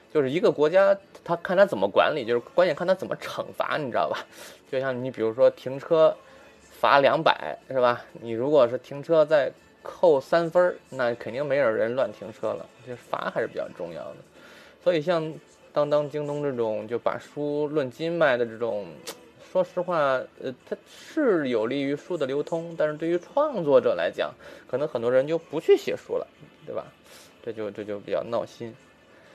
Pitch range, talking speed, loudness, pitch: 130-180 Hz, 270 characters per minute, -25 LUFS, 155 Hz